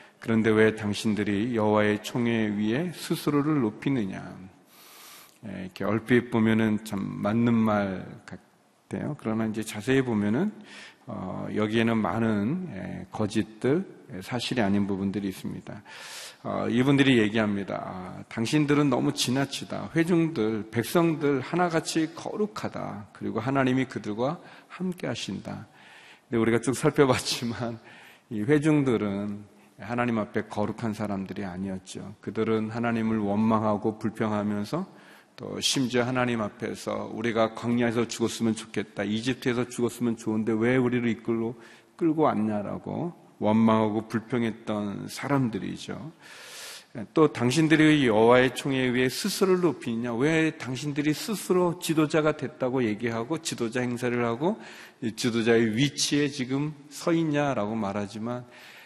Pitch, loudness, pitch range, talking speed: 115 Hz, -27 LUFS, 110-140 Hz, 305 characters per minute